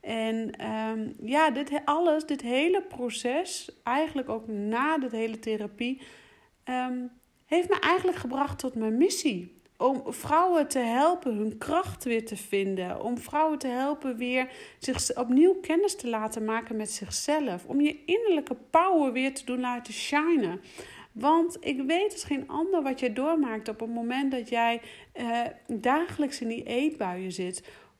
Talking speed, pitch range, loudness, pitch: 155 wpm, 230-310 Hz, -28 LUFS, 260 Hz